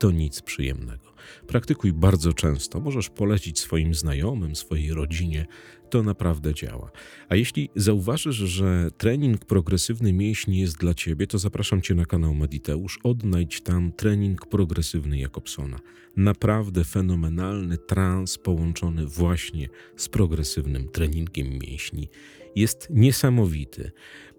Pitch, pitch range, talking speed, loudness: 90 Hz, 80-105 Hz, 115 wpm, -25 LUFS